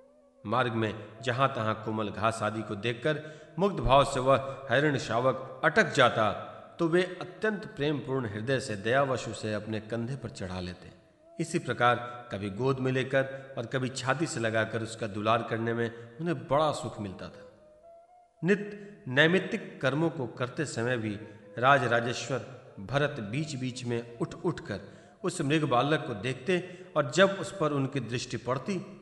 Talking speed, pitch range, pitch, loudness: 155 wpm, 115-160 Hz, 130 Hz, -30 LUFS